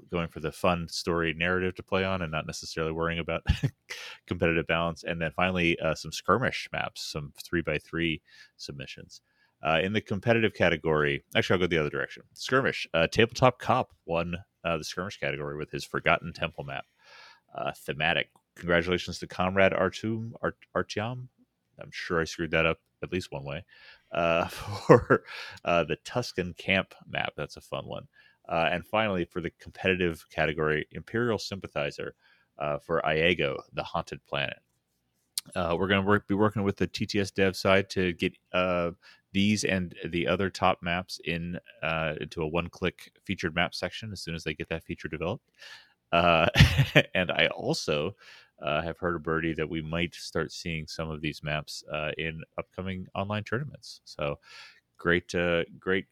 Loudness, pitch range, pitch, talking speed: -29 LUFS, 80-95 Hz, 85 Hz, 170 wpm